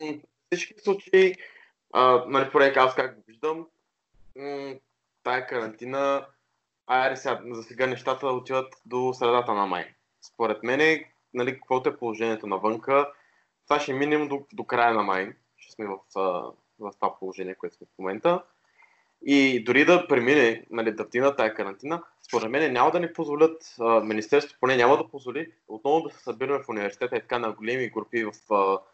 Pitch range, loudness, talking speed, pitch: 115-145 Hz, -25 LUFS, 165 wpm, 130 Hz